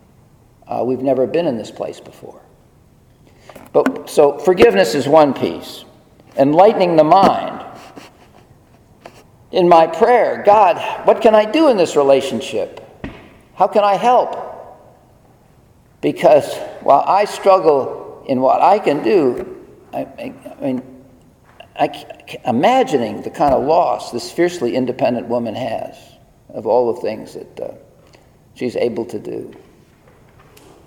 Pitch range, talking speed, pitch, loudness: 135-220 Hz, 130 wpm, 185 Hz, -15 LUFS